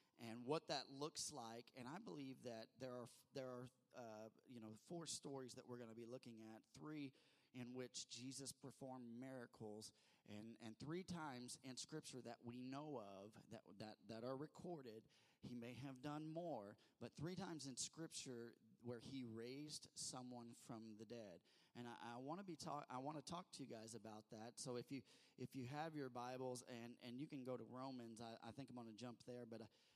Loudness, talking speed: -55 LUFS, 210 wpm